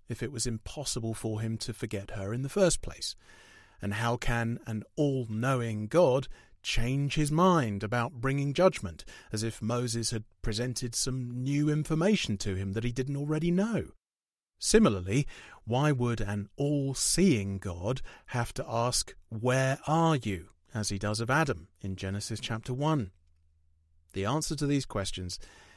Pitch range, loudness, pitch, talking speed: 105-140 Hz, -30 LUFS, 120 Hz, 160 wpm